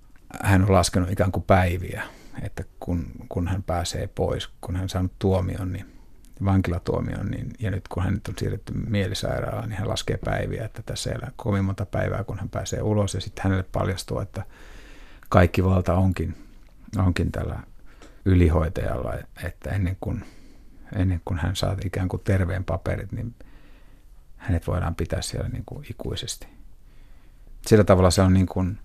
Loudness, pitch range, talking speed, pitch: -25 LUFS, 90-110 Hz, 160 wpm, 95 Hz